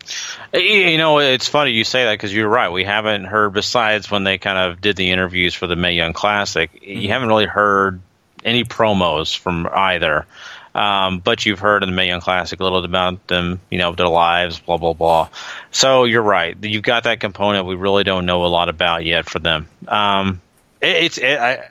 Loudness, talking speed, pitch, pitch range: -16 LUFS, 215 wpm, 95 Hz, 90-105 Hz